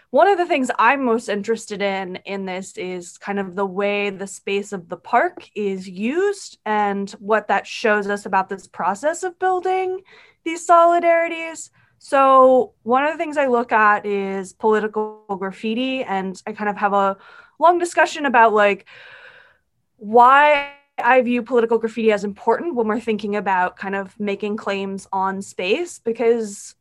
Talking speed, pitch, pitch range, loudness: 165 wpm, 220 Hz, 200-285 Hz, -19 LUFS